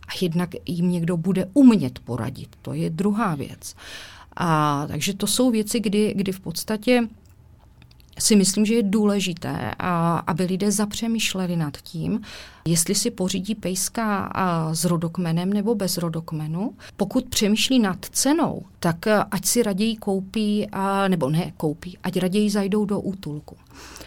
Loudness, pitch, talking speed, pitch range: -22 LUFS, 190 Hz, 145 wpm, 170-210 Hz